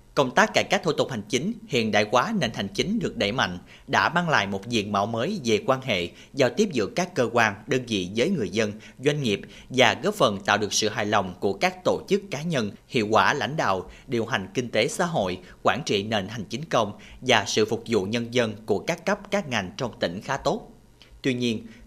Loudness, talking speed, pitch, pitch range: -25 LUFS, 240 wpm, 115 Hz, 105-135 Hz